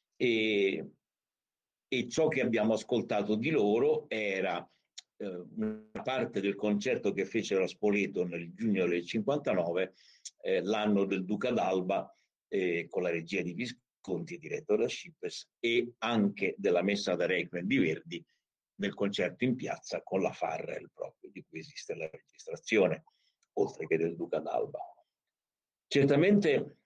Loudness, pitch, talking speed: -32 LUFS, 140 Hz, 140 wpm